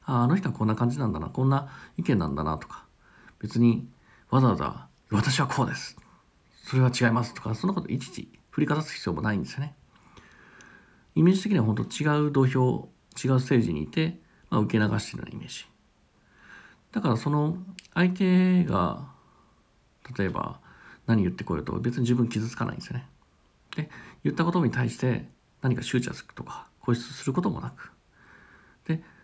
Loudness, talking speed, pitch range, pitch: -27 LUFS, 335 characters per minute, 110-150 Hz, 125 Hz